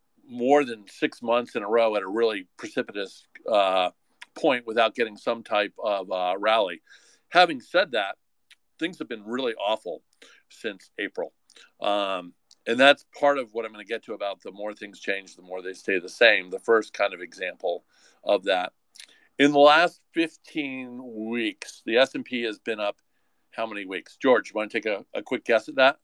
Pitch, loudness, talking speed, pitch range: 110 Hz, -25 LUFS, 190 wpm, 100-125 Hz